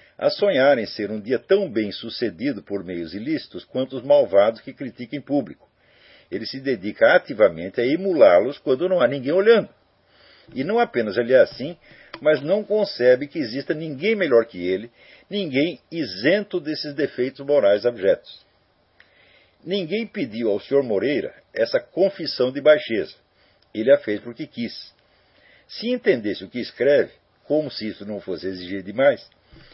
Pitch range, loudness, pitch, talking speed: 115-170 Hz, -21 LUFS, 140 Hz, 155 wpm